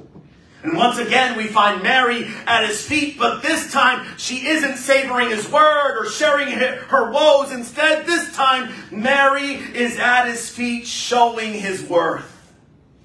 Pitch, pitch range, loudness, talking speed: 255 Hz, 235-280 Hz, -17 LUFS, 145 wpm